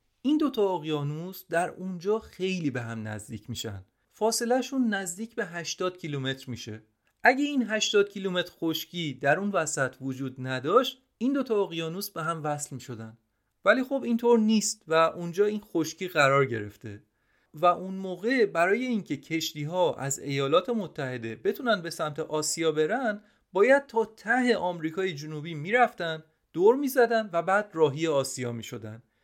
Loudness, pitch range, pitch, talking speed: -27 LUFS, 140-215 Hz, 170 Hz, 145 wpm